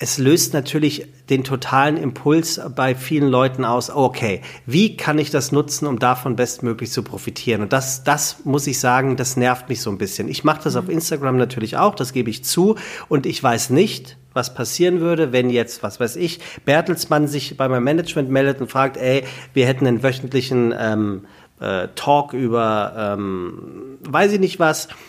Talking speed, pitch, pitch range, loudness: 185 wpm, 135 Hz, 125-150 Hz, -19 LUFS